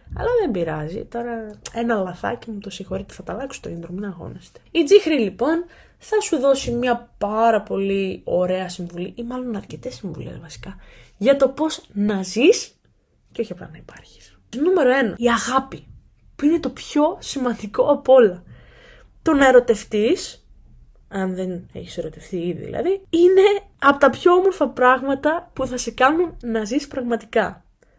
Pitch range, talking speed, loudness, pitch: 200-290 Hz, 160 wpm, -20 LUFS, 240 Hz